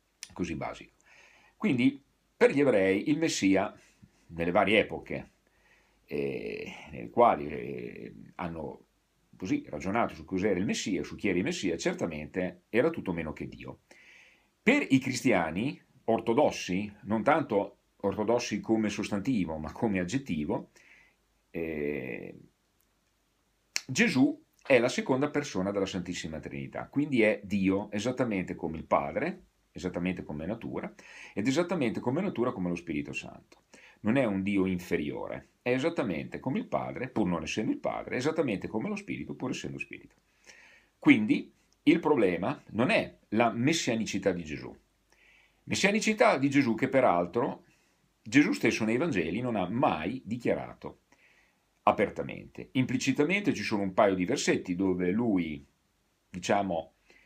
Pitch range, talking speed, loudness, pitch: 90-145 Hz, 135 wpm, -30 LUFS, 105 Hz